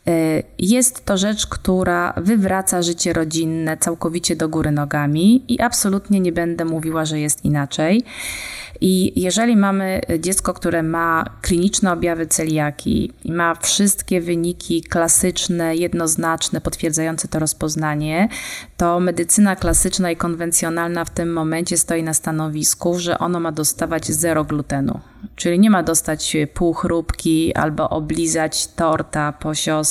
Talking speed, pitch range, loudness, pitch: 130 wpm, 160-185 Hz, -18 LUFS, 170 Hz